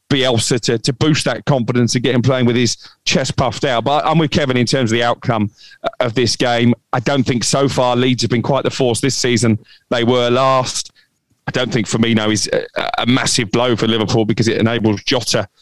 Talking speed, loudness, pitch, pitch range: 225 wpm, -16 LUFS, 125 Hz, 115-130 Hz